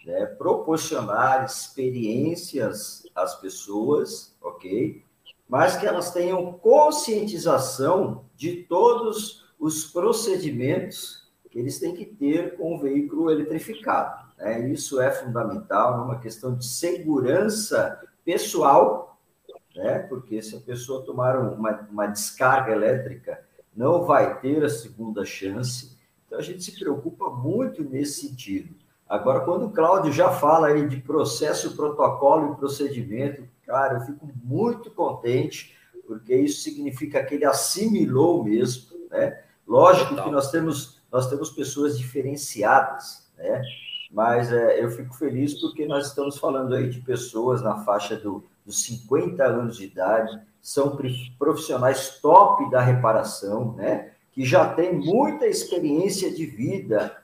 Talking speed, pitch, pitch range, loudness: 130 wpm, 140 Hz, 125-170 Hz, -23 LUFS